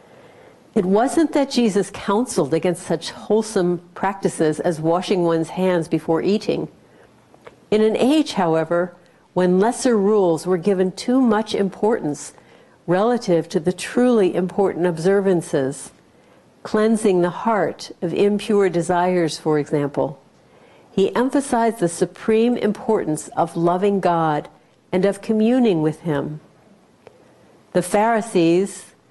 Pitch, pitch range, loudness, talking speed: 185 Hz, 170-215 Hz, -20 LUFS, 115 wpm